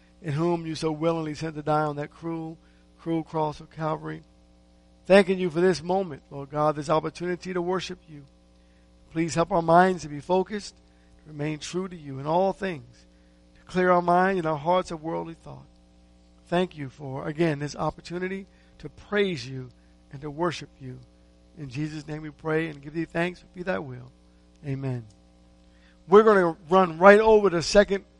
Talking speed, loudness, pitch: 185 wpm, -25 LUFS, 155 Hz